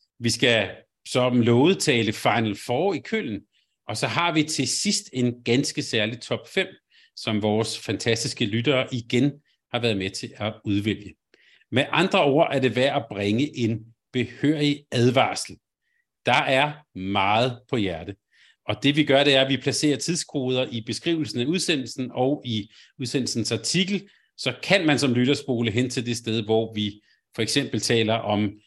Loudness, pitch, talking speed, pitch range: -23 LUFS, 125 Hz, 165 wpm, 110-145 Hz